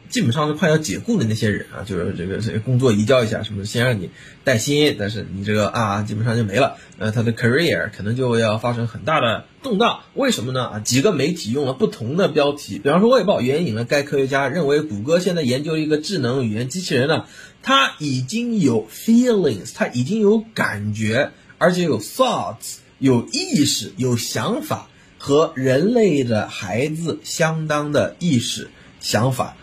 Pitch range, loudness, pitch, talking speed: 110-155 Hz, -19 LUFS, 130 Hz, 320 characters per minute